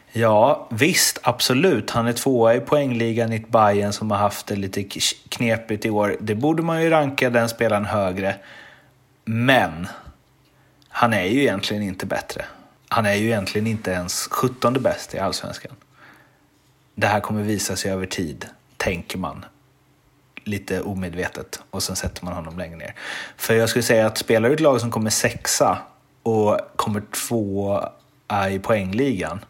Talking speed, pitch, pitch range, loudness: 160 wpm, 105 Hz, 100-115 Hz, -21 LUFS